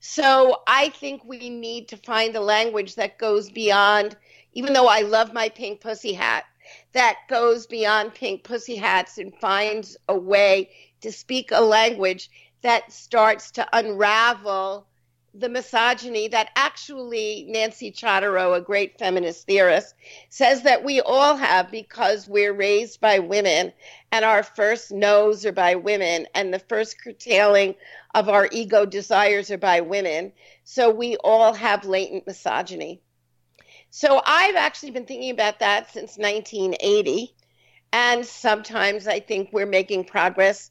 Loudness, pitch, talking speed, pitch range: -20 LUFS, 215 Hz, 145 wpm, 200-235 Hz